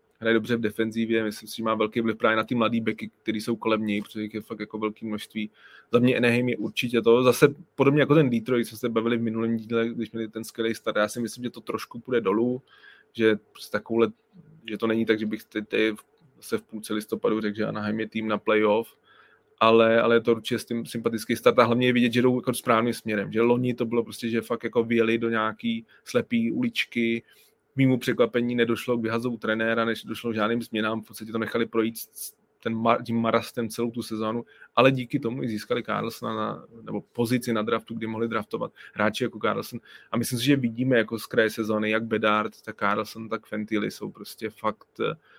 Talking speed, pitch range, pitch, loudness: 215 wpm, 110-120 Hz, 115 Hz, -26 LUFS